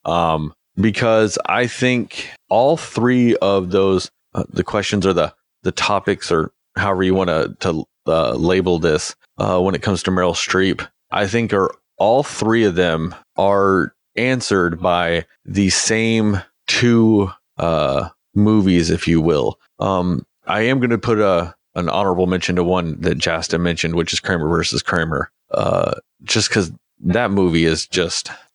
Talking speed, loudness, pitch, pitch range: 160 wpm, -18 LUFS, 95 Hz, 85-110 Hz